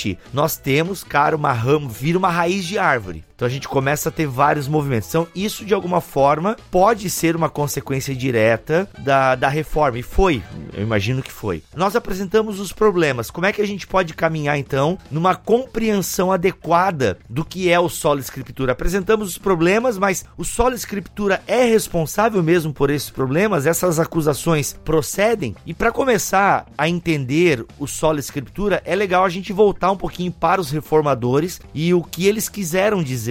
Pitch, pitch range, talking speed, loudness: 165 Hz, 140-195 Hz, 175 wpm, -19 LUFS